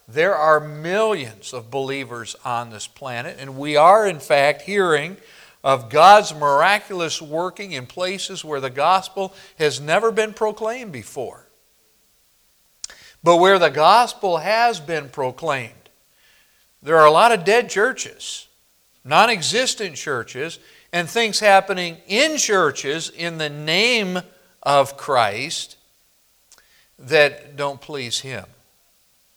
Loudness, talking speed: -18 LUFS, 120 wpm